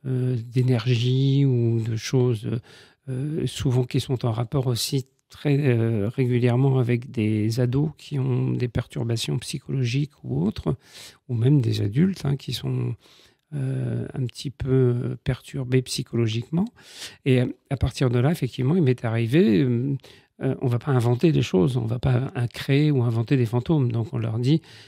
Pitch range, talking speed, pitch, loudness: 120-135 Hz, 160 wpm, 125 Hz, -24 LUFS